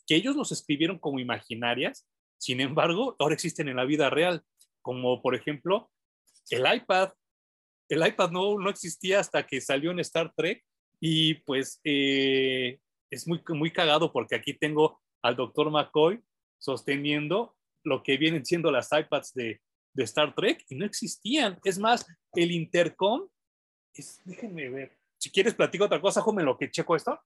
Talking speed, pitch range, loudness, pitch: 165 wpm, 135-185 Hz, -27 LUFS, 155 Hz